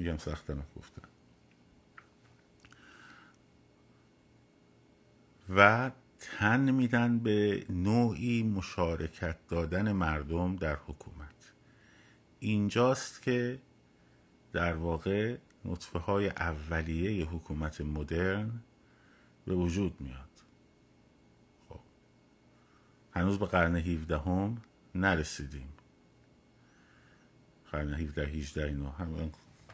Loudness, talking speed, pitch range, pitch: -32 LUFS, 75 wpm, 75-105 Hz, 85 Hz